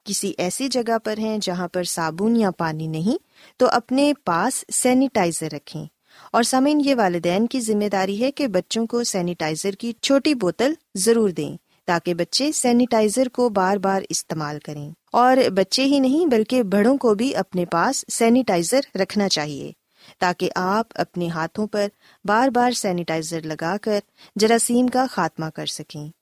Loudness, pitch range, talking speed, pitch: -21 LUFS, 175-245 Hz, 160 wpm, 210 Hz